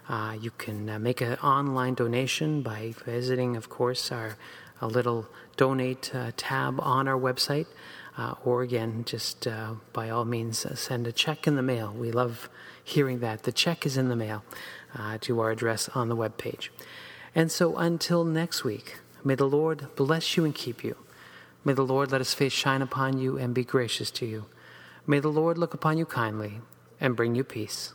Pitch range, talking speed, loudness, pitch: 115-140 Hz, 195 wpm, -28 LUFS, 125 Hz